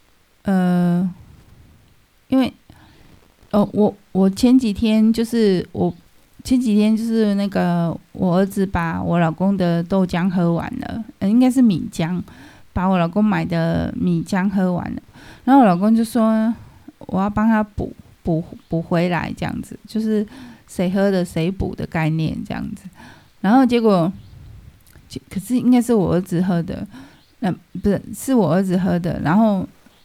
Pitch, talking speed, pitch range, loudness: 195 Hz, 215 characters per minute, 175-225 Hz, -19 LUFS